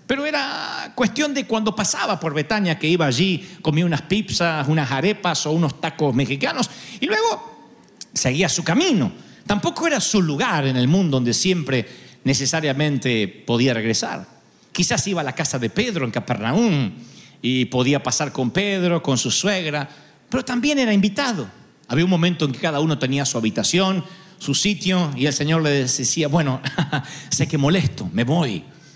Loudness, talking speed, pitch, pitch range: -20 LUFS, 170 wpm, 155 Hz, 135-190 Hz